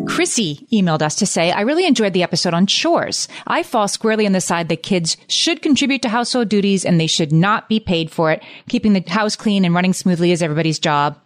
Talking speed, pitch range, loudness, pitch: 230 wpm, 170-225 Hz, -17 LUFS, 195 Hz